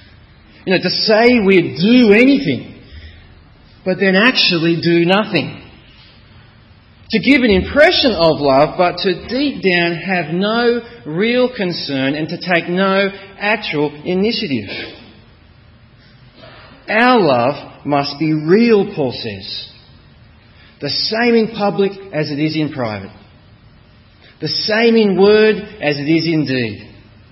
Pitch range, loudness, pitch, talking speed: 130-205 Hz, -14 LUFS, 170 Hz, 125 wpm